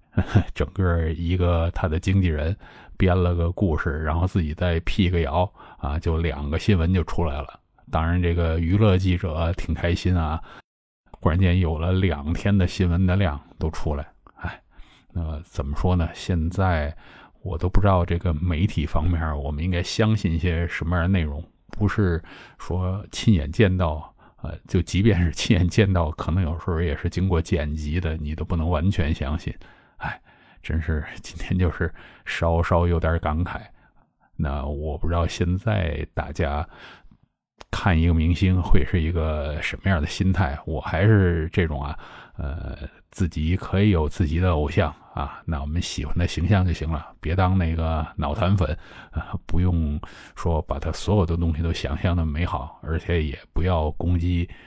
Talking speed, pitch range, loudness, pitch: 245 characters per minute, 80-95 Hz, -24 LUFS, 85 Hz